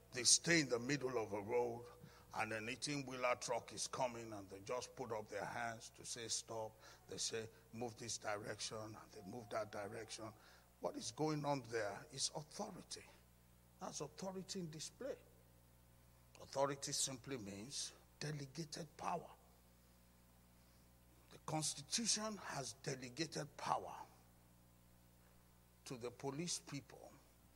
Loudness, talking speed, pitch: -44 LUFS, 130 wpm, 115 Hz